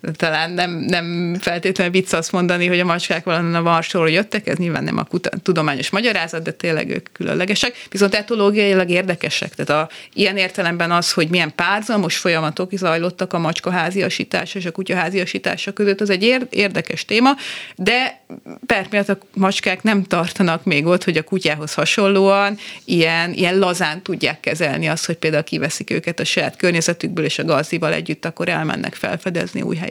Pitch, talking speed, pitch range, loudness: 180 Hz, 165 wpm, 170-195 Hz, -18 LUFS